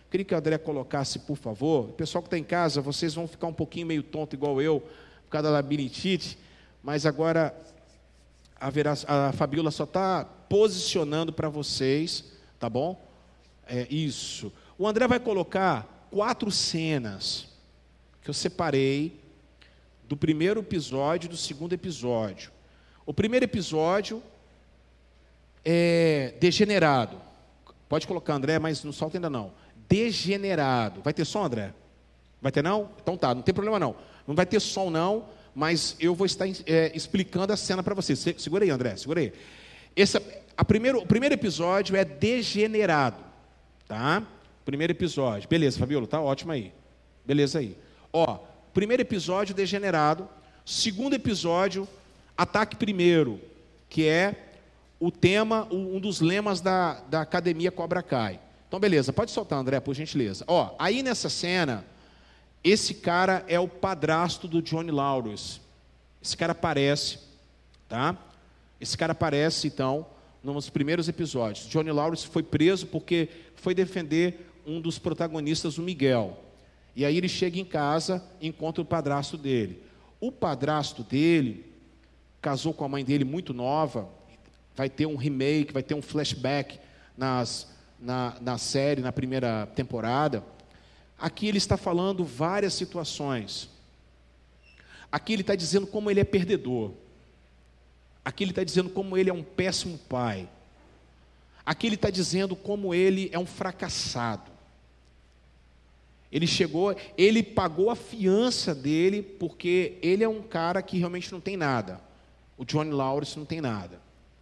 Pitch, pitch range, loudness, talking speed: 155 Hz, 125-185 Hz, -27 LUFS, 145 wpm